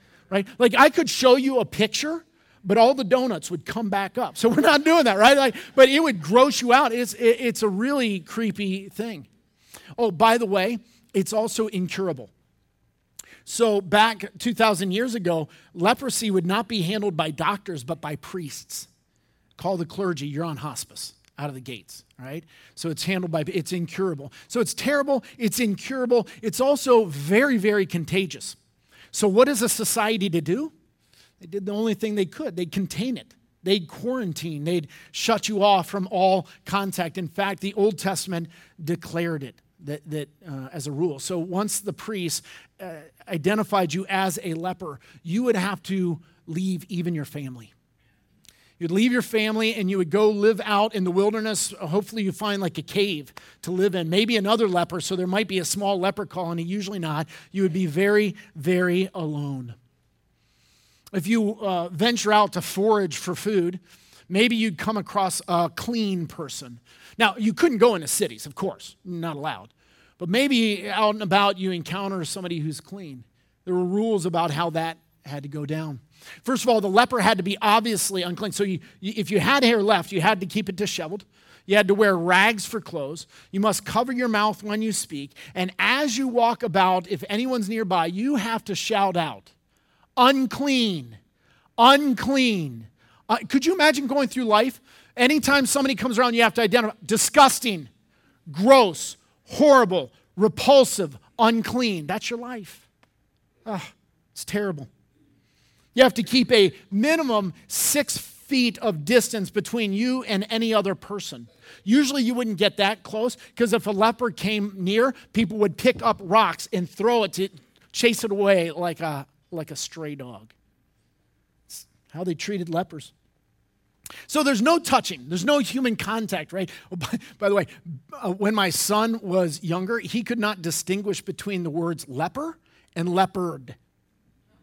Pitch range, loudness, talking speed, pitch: 175-225 Hz, -23 LUFS, 175 wpm, 200 Hz